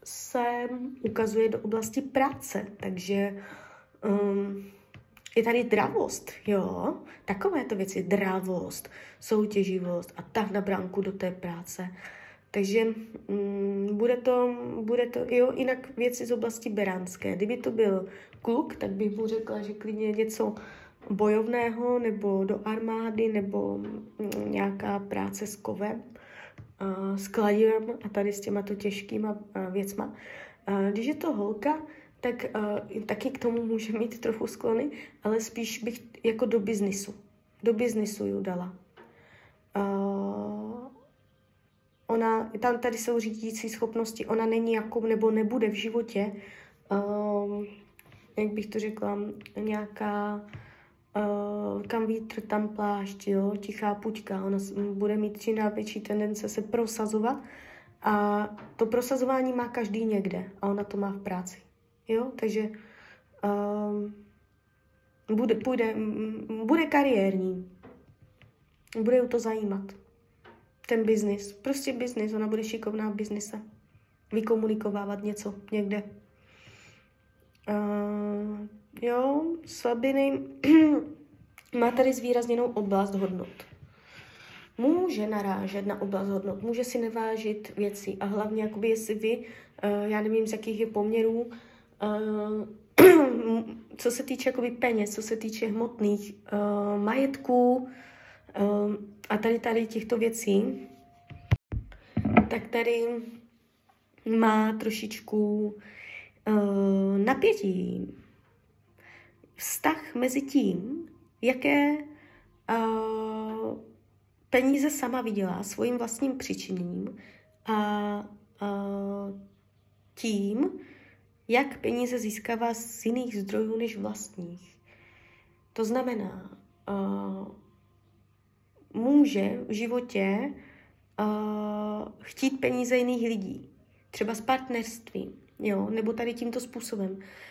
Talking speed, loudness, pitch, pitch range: 110 wpm, -29 LUFS, 215 Hz, 200-235 Hz